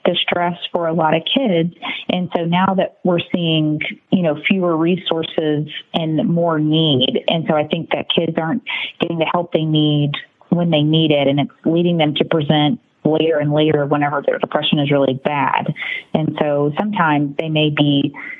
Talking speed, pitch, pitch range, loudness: 185 wpm, 160 Hz, 150-175 Hz, -17 LUFS